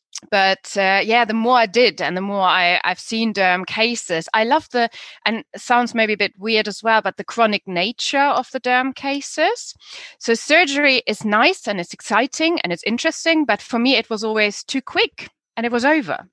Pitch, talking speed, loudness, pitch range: 225 Hz, 210 wpm, -18 LUFS, 200-260 Hz